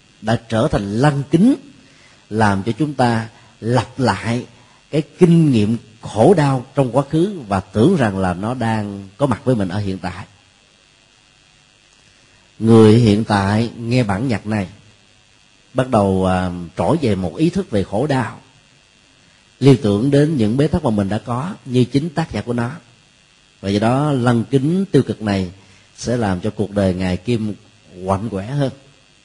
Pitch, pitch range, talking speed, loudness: 115 Hz, 105-135 Hz, 170 wpm, -17 LUFS